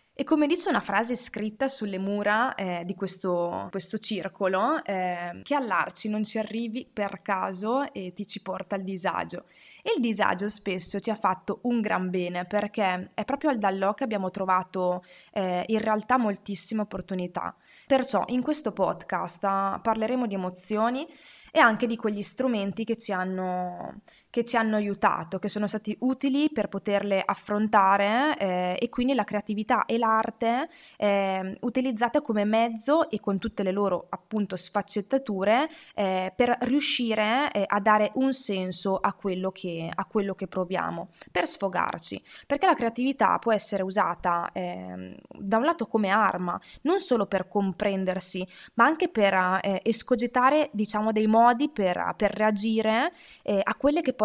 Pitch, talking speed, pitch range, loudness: 210 Hz, 160 wpm, 190-240 Hz, -24 LUFS